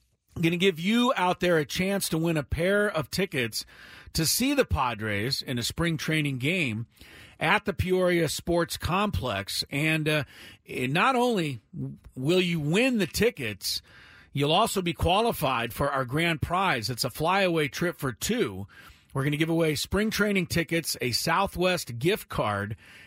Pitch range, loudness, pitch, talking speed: 130-185 Hz, -26 LUFS, 160 Hz, 165 wpm